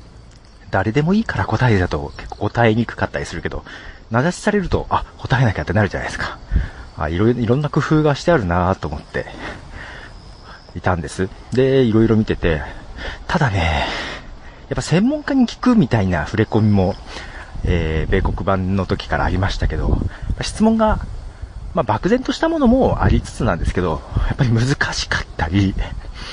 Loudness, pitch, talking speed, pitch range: -19 LUFS, 105 Hz, 325 characters per minute, 90-135 Hz